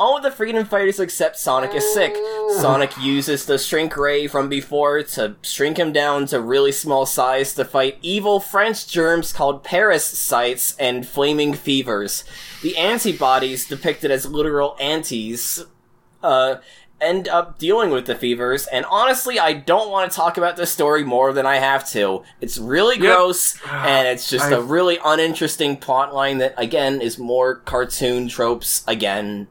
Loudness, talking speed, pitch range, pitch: -19 LUFS, 160 wpm, 130-175 Hz, 140 Hz